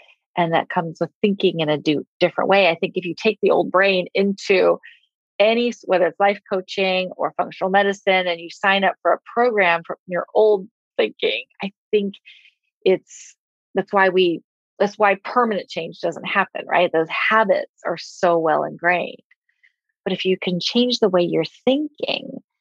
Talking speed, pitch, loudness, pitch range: 175 wpm, 195 Hz, -20 LUFS, 180-220 Hz